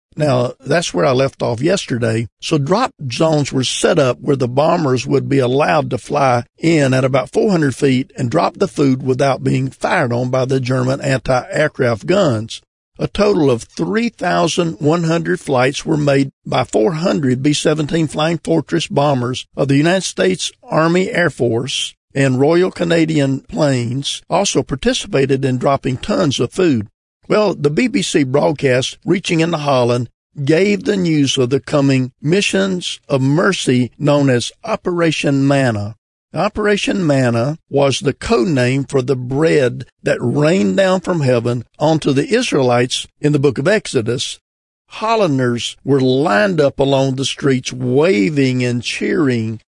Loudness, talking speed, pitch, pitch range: -16 LUFS, 145 wpm, 140 Hz, 125-165 Hz